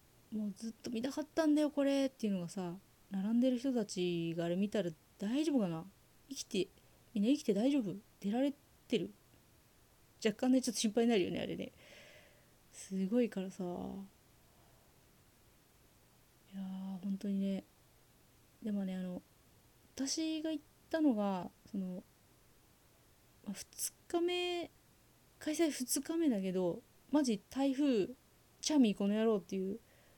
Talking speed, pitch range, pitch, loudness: 255 characters per minute, 195-275 Hz, 225 Hz, -37 LUFS